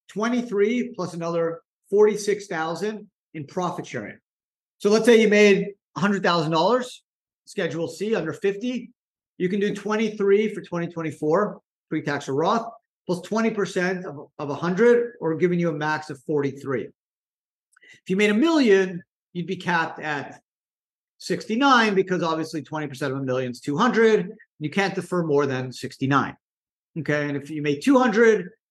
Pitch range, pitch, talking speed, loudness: 155-210 Hz, 180 Hz, 145 wpm, -23 LUFS